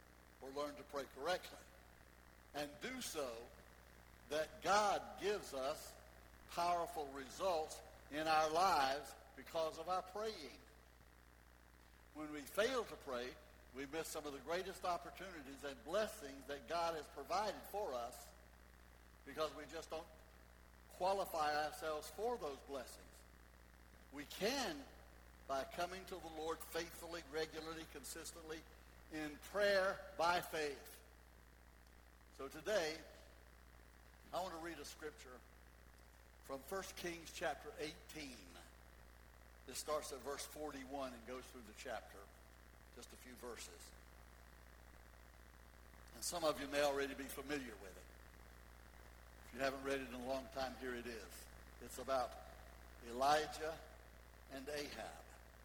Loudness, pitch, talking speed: -44 LUFS, 125 Hz, 125 wpm